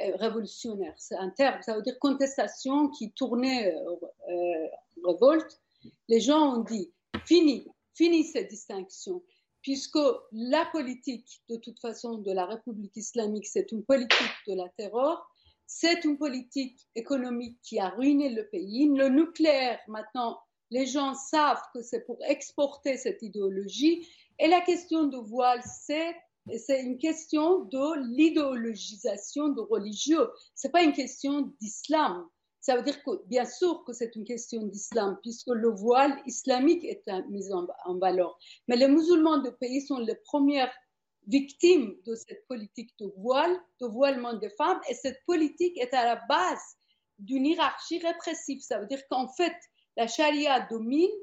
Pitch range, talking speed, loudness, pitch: 225-300 Hz, 160 wpm, -28 LUFS, 260 Hz